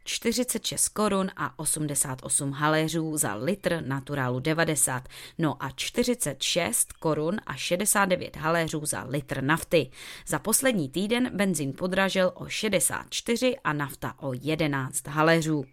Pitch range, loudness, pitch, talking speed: 140-185 Hz, -26 LUFS, 155 Hz, 120 wpm